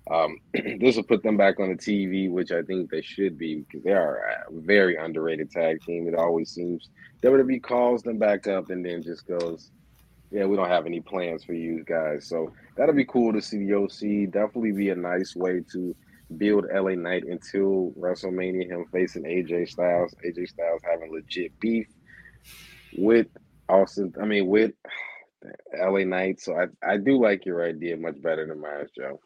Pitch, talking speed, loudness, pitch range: 90 Hz, 185 wpm, -26 LUFS, 85-100 Hz